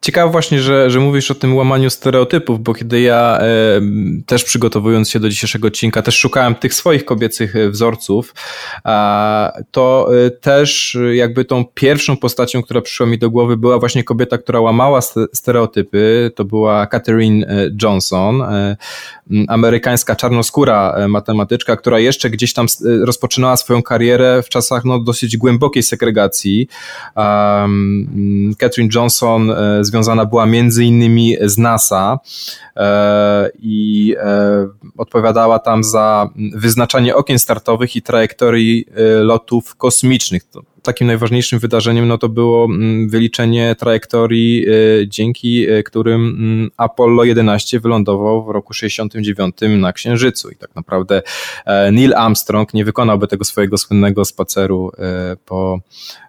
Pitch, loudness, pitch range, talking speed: 115 Hz, -13 LUFS, 105-120 Hz, 125 wpm